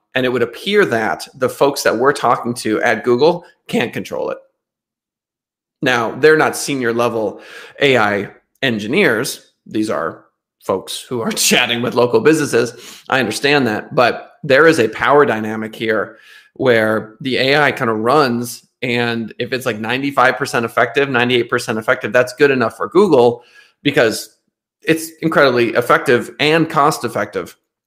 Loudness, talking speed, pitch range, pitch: -15 LUFS, 145 wpm, 115-145 Hz, 125 Hz